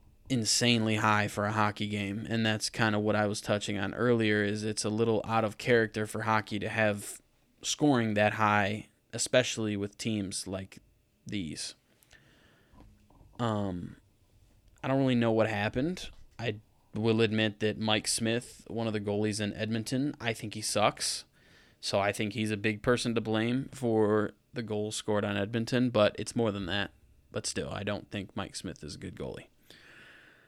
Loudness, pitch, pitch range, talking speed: -30 LUFS, 110 Hz, 105-115 Hz, 175 wpm